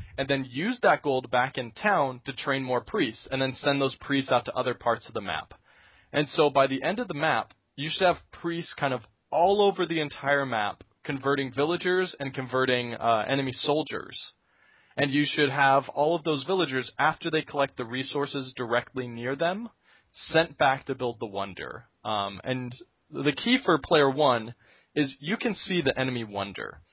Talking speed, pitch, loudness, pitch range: 190 wpm, 140 Hz, -27 LUFS, 125-155 Hz